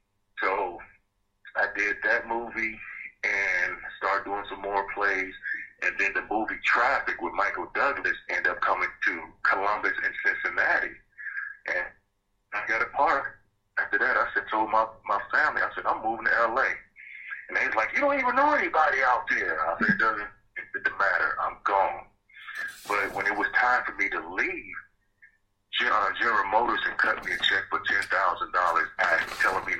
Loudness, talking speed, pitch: -26 LUFS, 175 wpm, 295 Hz